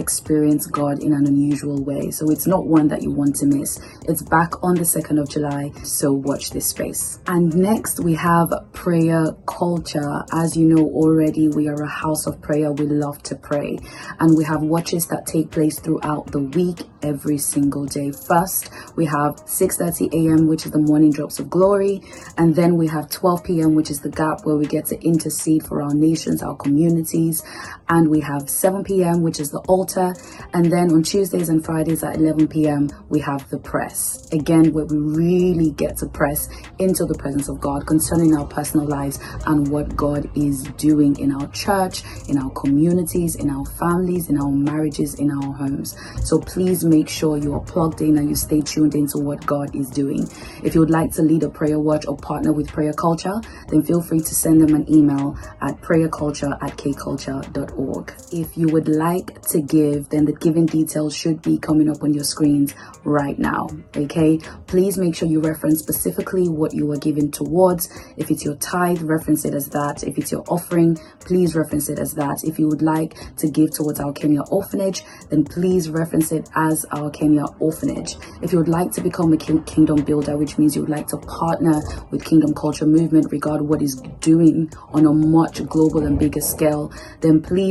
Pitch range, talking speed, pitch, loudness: 145-165 Hz, 200 wpm, 155 Hz, -19 LUFS